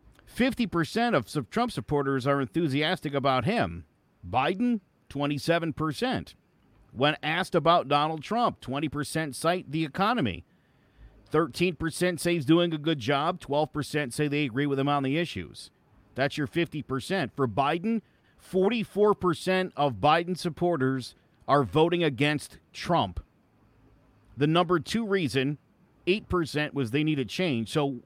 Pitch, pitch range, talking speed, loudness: 150 Hz, 140-175 Hz, 125 wpm, -27 LUFS